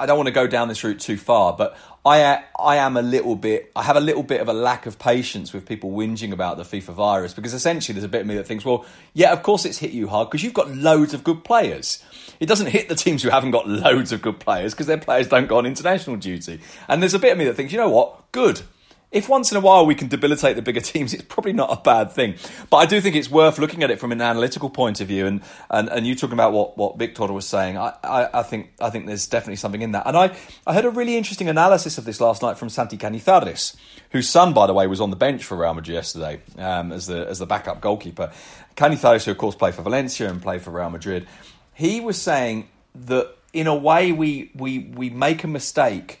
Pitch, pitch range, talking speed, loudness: 125 Hz, 105-155 Hz, 265 wpm, -20 LUFS